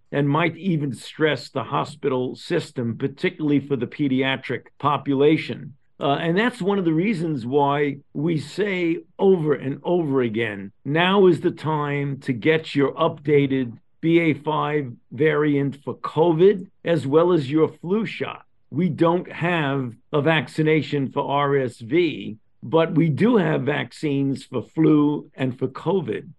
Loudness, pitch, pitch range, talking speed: -22 LUFS, 150 Hz, 135-165 Hz, 140 wpm